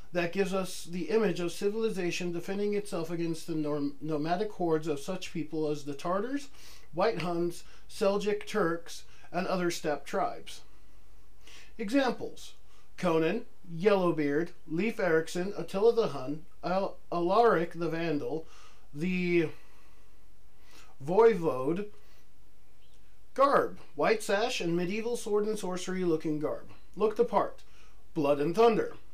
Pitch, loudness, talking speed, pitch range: 175 Hz, -31 LUFS, 115 wpm, 155-205 Hz